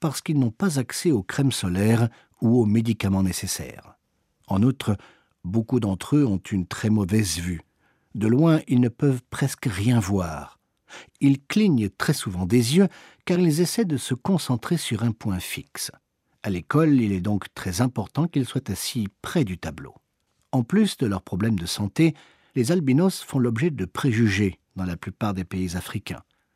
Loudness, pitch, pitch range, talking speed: -24 LUFS, 120 Hz, 100-140 Hz, 175 wpm